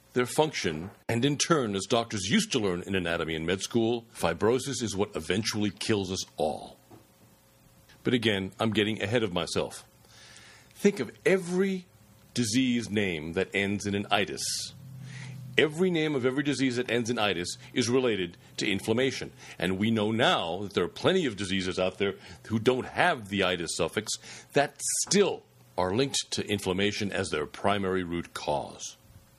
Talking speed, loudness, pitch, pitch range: 165 wpm, -28 LUFS, 110 Hz, 95-130 Hz